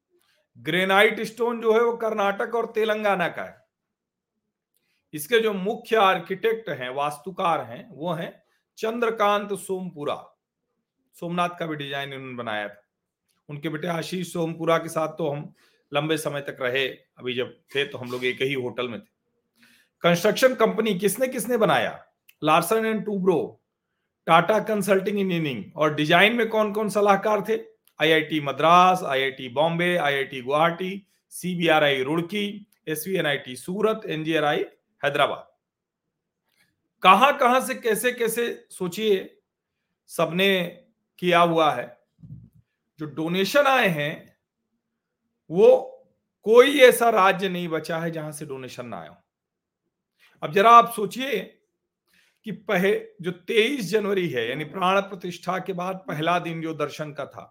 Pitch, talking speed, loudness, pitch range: 185 Hz, 135 wpm, -23 LUFS, 155-215 Hz